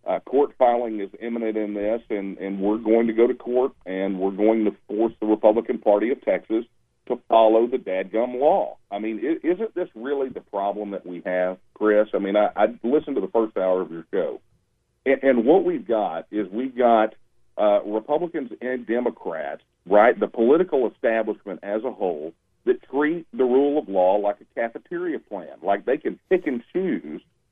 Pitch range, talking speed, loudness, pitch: 105-130 Hz, 190 wpm, -23 LUFS, 110 Hz